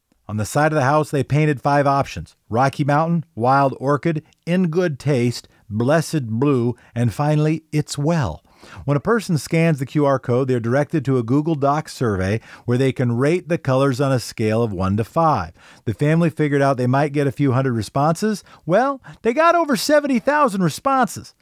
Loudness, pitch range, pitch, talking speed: -19 LUFS, 125-165 Hz, 145 Hz, 190 wpm